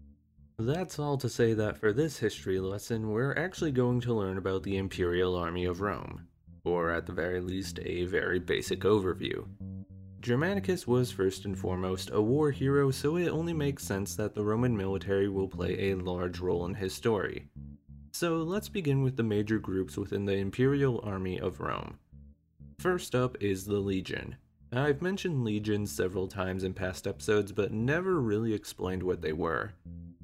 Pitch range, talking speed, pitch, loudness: 90-125 Hz, 175 wpm, 100 Hz, -31 LUFS